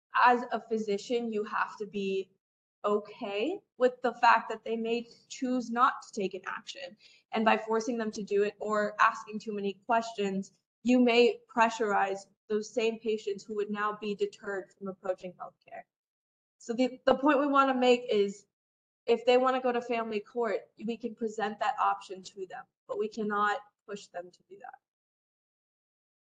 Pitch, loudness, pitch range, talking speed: 220 Hz, -30 LUFS, 205-245 Hz, 180 wpm